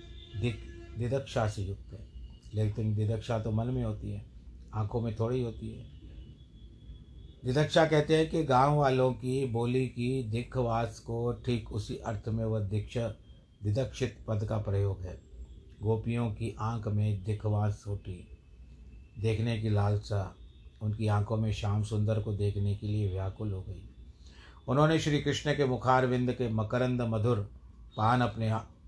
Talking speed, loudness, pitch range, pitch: 150 wpm, -31 LUFS, 100-120 Hz, 110 Hz